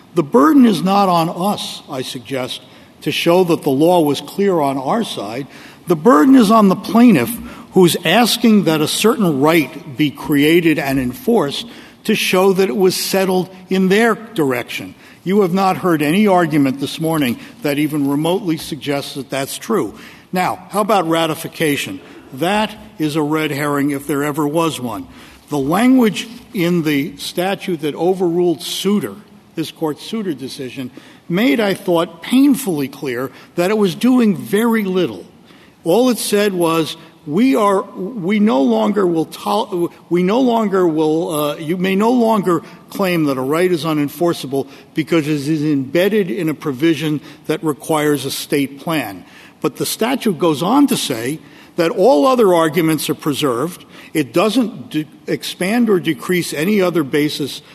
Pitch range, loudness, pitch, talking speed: 150-205 Hz, -16 LUFS, 170 Hz, 160 wpm